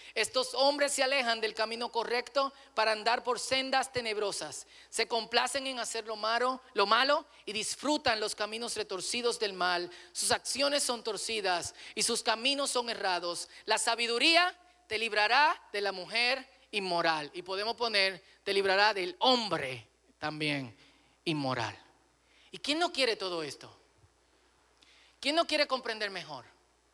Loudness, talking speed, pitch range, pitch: -30 LUFS, 145 wpm, 195-255 Hz, 225 Hz